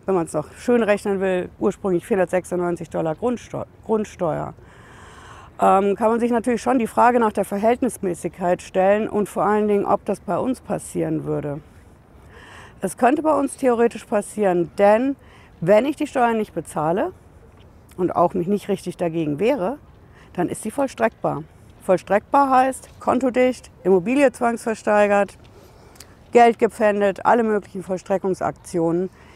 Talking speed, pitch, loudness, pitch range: 135 wpm, 200 Hz, -21 LUFS, 175-230 Hz